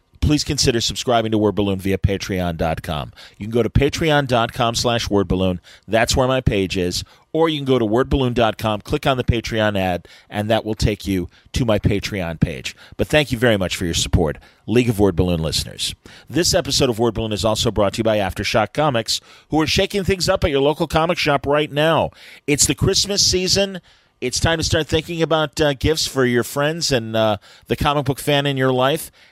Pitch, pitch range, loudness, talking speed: 120 Hz, 105-150 Hz, -19 LUFS, 210 wpm